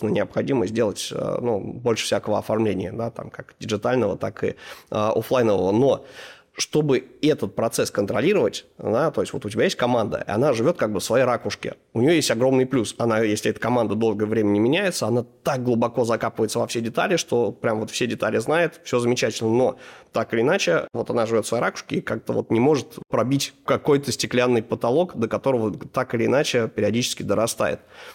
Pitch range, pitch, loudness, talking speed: 110-130 Hz, 120 Hz, -22 LUFS, 190 wpm